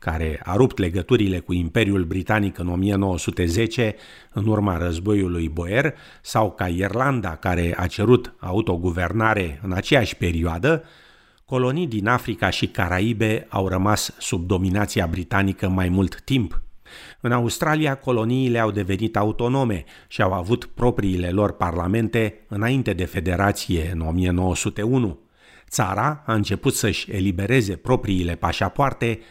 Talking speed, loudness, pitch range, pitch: 125 wpm, -22 LUFS, 90-115 Hz, 100 Hz